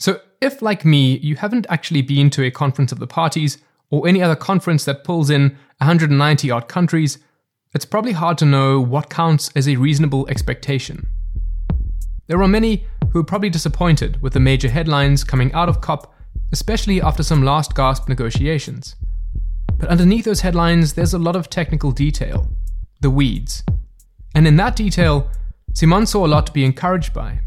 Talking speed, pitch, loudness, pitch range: 175 wpm, 145 Hz, -17 LUFS, 130-170 Hz